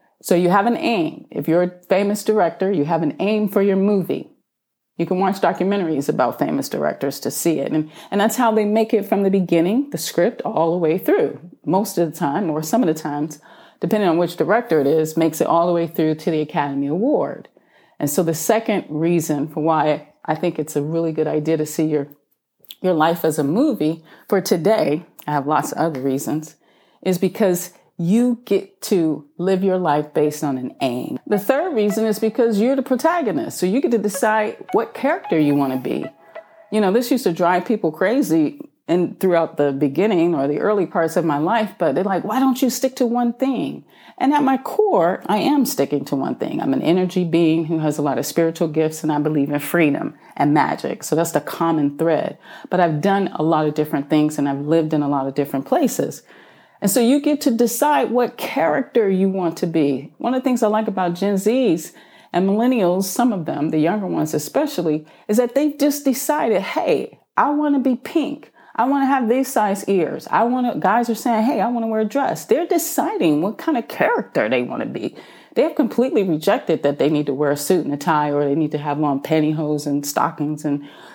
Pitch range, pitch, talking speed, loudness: 155-230 Hz, 180 Hz, 225 wpm, -19 LUFS